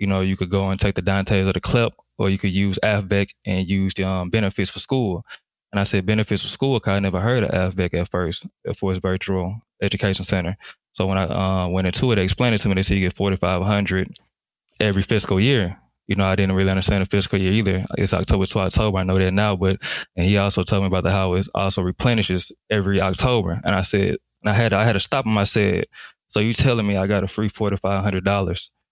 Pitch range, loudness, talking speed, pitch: 95-105 Hz, -21 LUFS, 255 wpm, 95 Hz